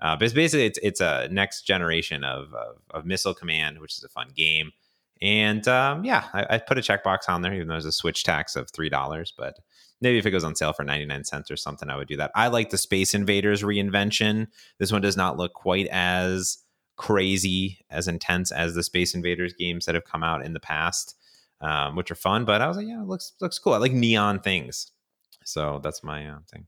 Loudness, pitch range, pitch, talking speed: -24 LUFS, 80-105 Hz, 90 Hz, 235 wpm